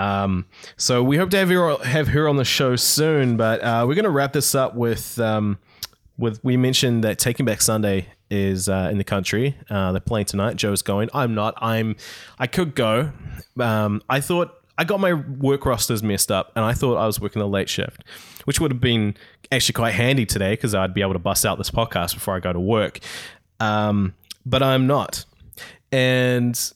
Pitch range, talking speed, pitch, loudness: 105-130 Hz, 210 wpm, 115 Hz, -21 LUFS